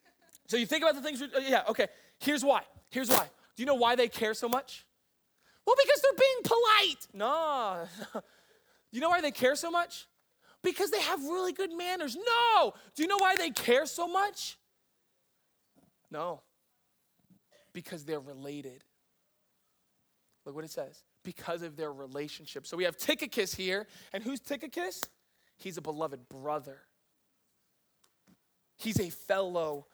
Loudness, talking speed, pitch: -31 LUFS, 155 wpm, 260 Hz